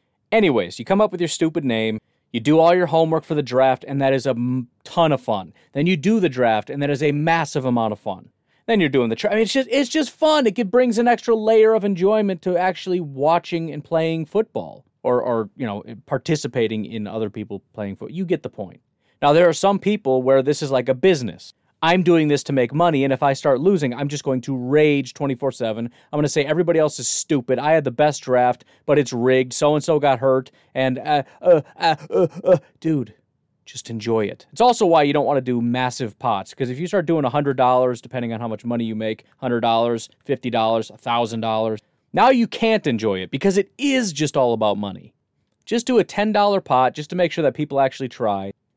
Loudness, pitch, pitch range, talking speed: -20 LUFS, 145 Hz, 125-175 Hz, 230 wpm